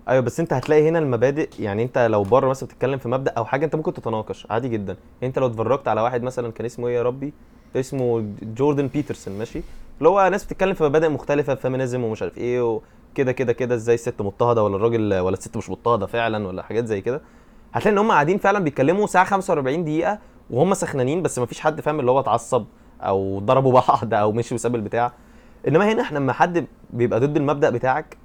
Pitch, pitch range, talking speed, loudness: 125 Hz, 115-150 Hz, 210 wpm, -21 LUFS